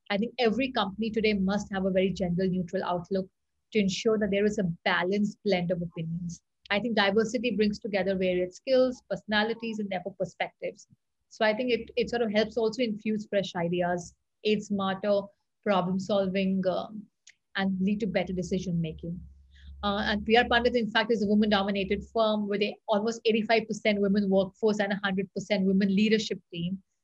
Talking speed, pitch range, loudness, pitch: 170 wpm, 190-220 Hz, -28 LUFS, 205 Hz